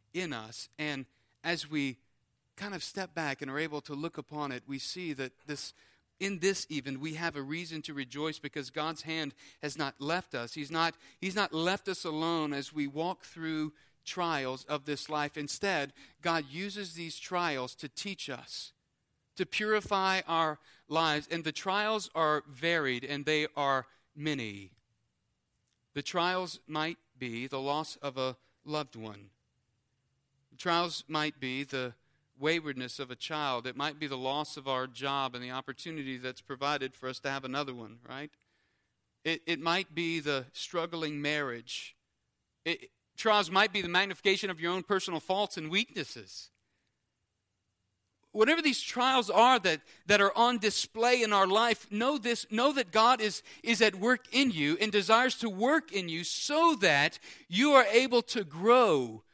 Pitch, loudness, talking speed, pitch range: 155 Hz, -31 LUFS, 170 wpm, 135-190 Hz